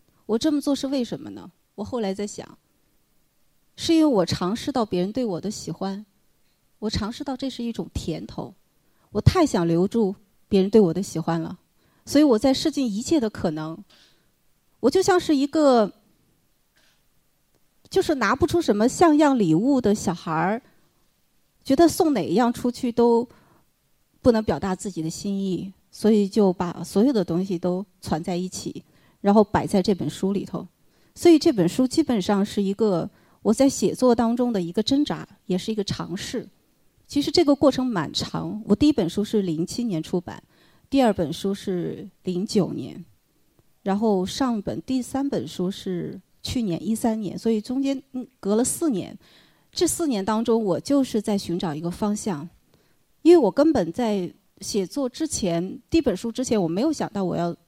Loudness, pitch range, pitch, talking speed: -23 LUFS, 185-260 Hz, 215 Hz, 250 characters per minute